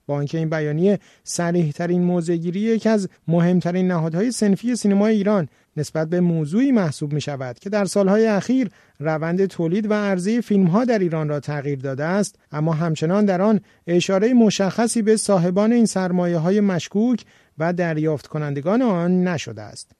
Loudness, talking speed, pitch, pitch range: -20 LUFS, 155 wpm, 180 Hz, 160-210 Hz